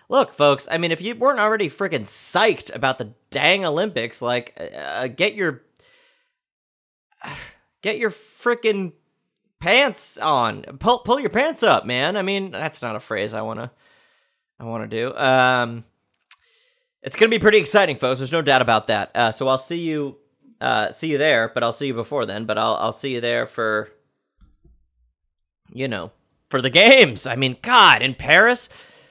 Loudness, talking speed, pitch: -19 LUFS, 175 wpm, 140 Hz